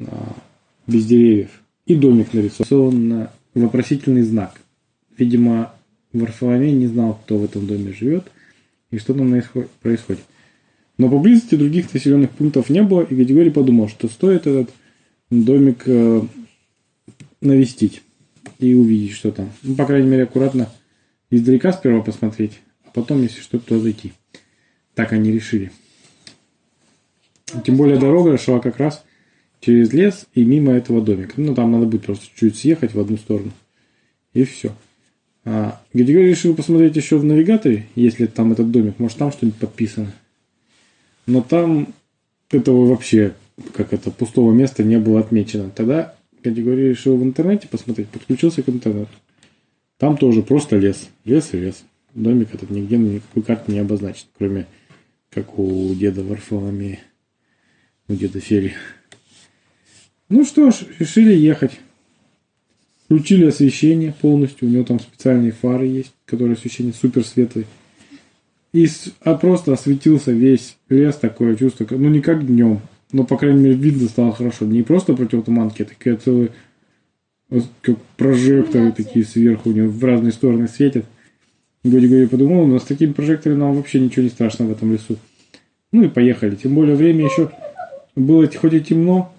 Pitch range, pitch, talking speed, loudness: 110-140 Hz, 120 Hz, 145 wpm, -16 LUFS